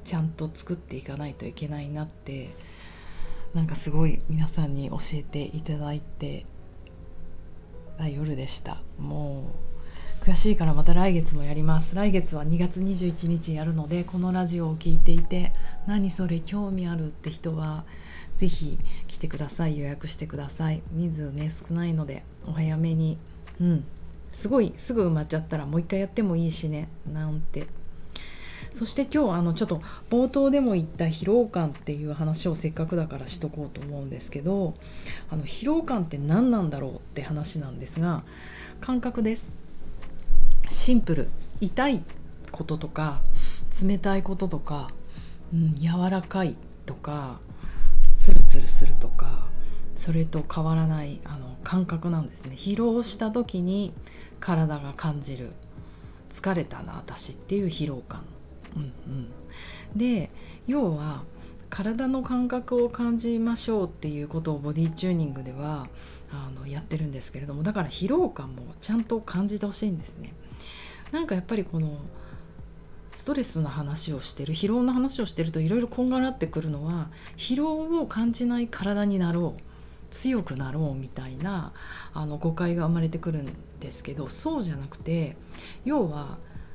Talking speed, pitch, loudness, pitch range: 310 characters per minute, 160 Hz, -29 LUFS, 145-190 Hz